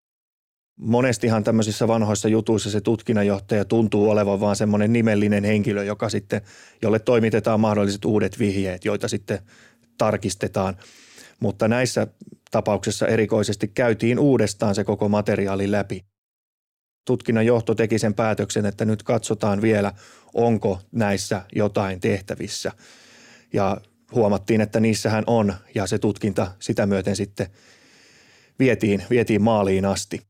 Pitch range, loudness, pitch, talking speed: 100-115 Hz, -22 LUFS, 105 Hz, 115 wpm